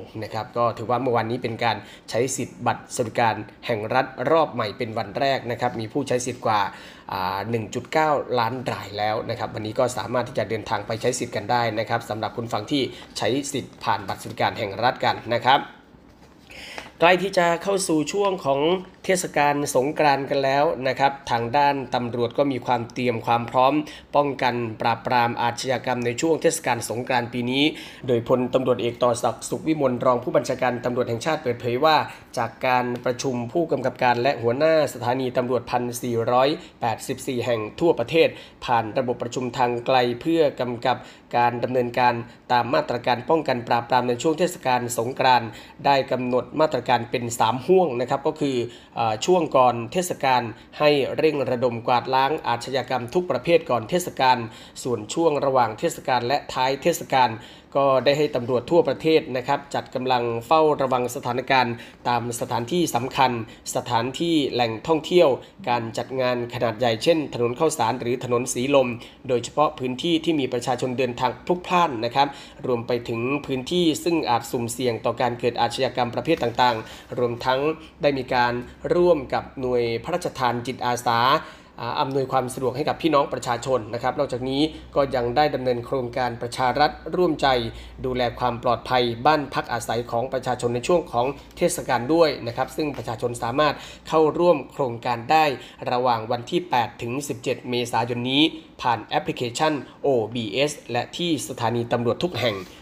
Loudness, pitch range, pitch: -23 LUFS, 120-145 Hz, 125 Hz